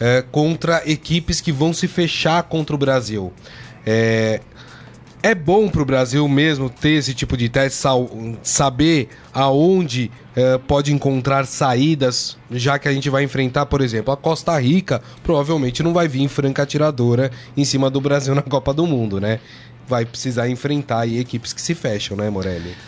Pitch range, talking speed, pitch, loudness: 125-150 Hz, 170 wpm, 135 Hz, -18 LUFS